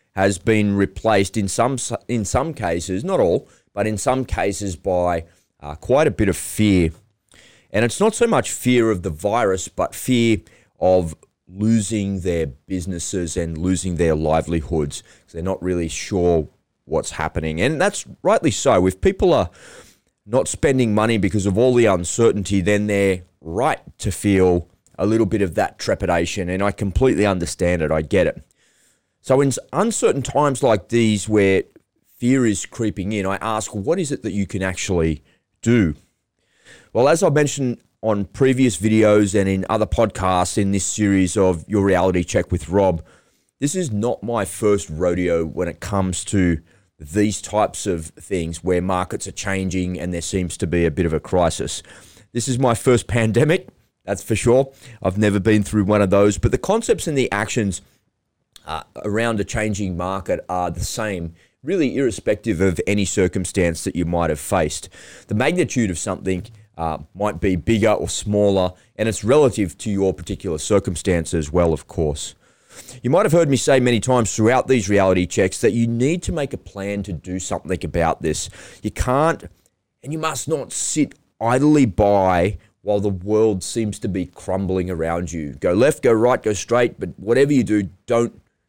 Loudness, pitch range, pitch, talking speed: -20 LUFS, 90-110 Hz, 100 Hz, 180 wpm